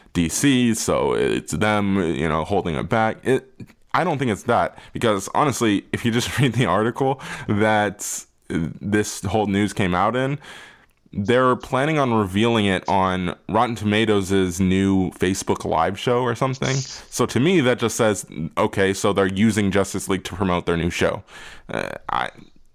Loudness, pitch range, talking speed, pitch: -21 LUFS, 95-120 Hz, 165 wpm, 105 Hz